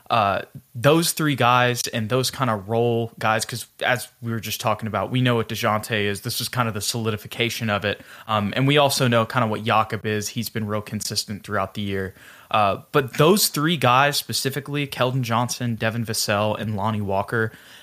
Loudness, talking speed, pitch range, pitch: -22 LUFS, 200 wpm, 110-130 Hz, 115 Hz